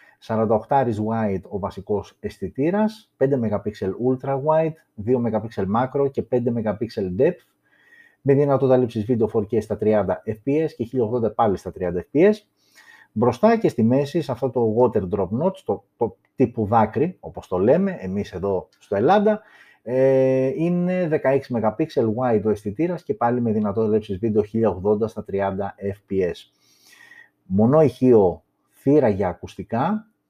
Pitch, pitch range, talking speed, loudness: 120 Hz, 110-140 Hz, 145 wpm, -22 LUFS